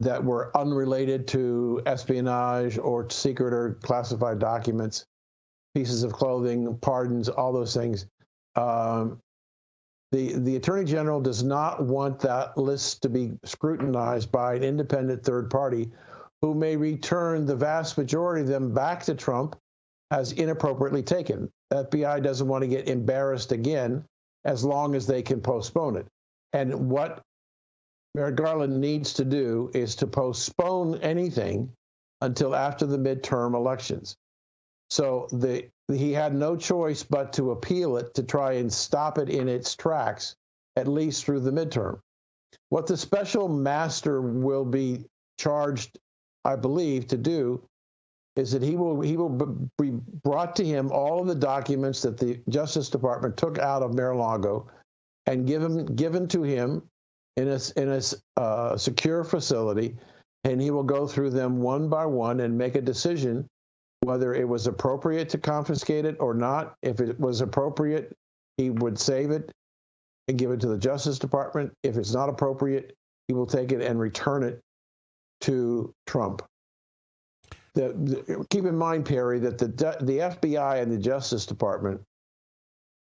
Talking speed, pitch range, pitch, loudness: 155 wpm, 120-145 Hz, 135 Hz, -27 LUFS